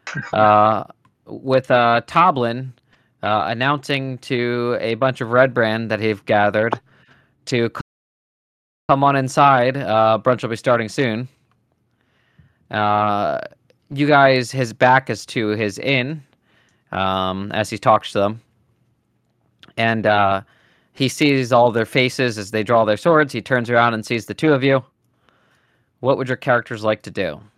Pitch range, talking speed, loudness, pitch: 110-130 Hz, 145 wpm, -18 LUFS, 120 Hz